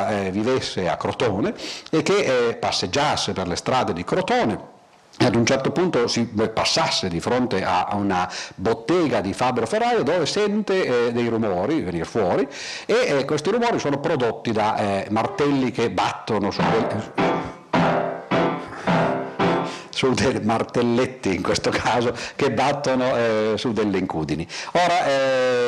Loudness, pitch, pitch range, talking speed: -22 LUFS, 120 Hz, 105-135 Hz, 145 wpm